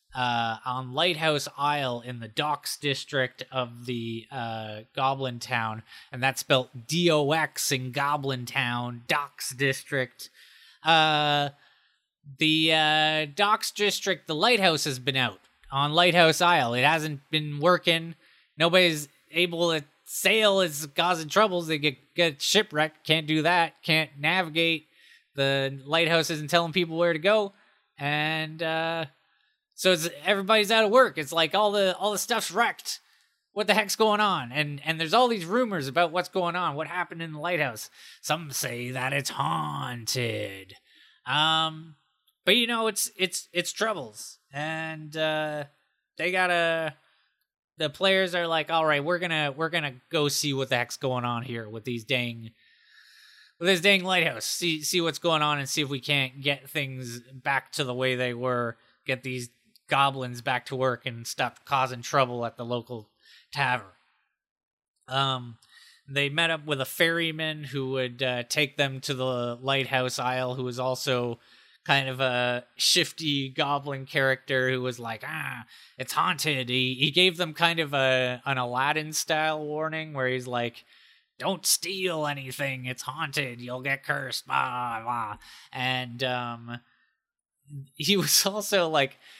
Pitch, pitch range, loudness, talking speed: 150 Hz, 130-170 Hz, -26 LUFS, 155 wpm